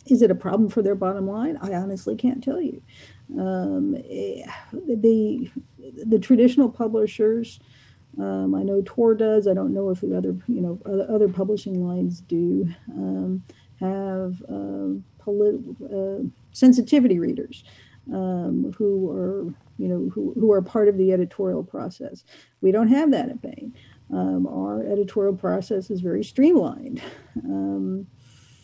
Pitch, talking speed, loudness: 195 Hz, 145 wpm, -23 LUFS